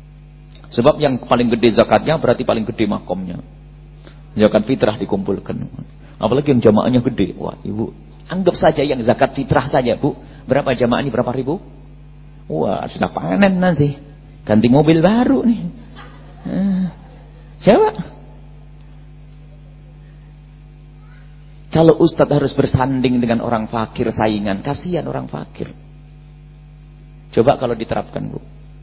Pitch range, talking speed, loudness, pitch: 125-150 Hz, 115 wpm, -17 LUFS, 150 Hz